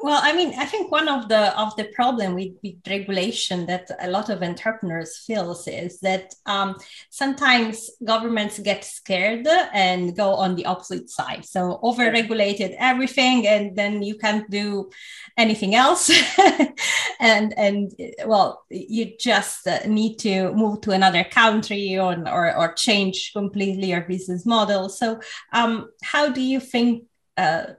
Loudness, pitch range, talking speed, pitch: -21 LUFS, 190-240 Hz, 150 wpm, 210 Hz